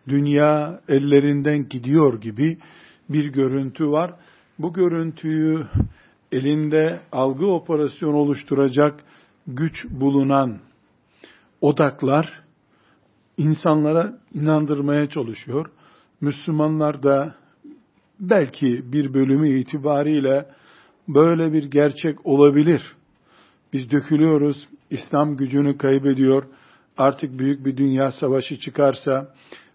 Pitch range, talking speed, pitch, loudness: 135-155 Hz, 80 wpm, 145 Hz, -20 LUFS